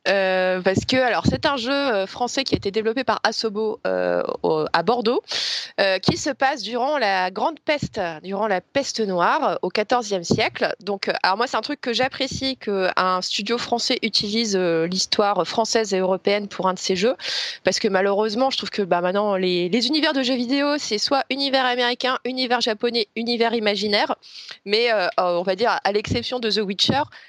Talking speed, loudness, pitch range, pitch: 190 wpm, -21 LUFS, 190-255 Hz, 220 Hz